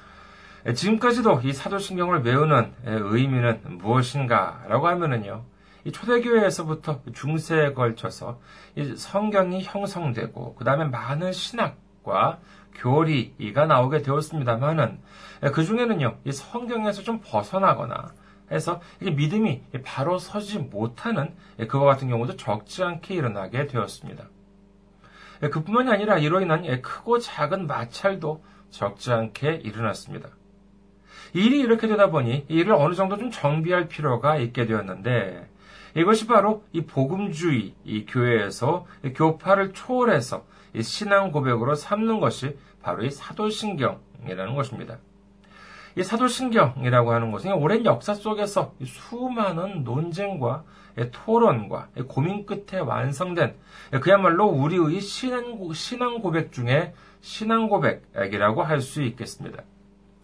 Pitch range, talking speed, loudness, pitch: 125-200 Hz, 280 characters per minute, -24 LUFS, 155 Hz